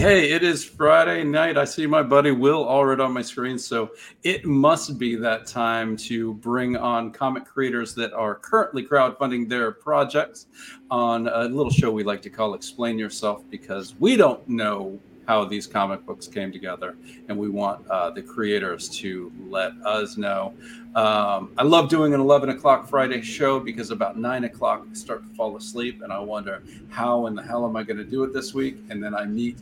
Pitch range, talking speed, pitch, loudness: 110-140 Hz, 200 wpm, 120 Hz, -23 LUFS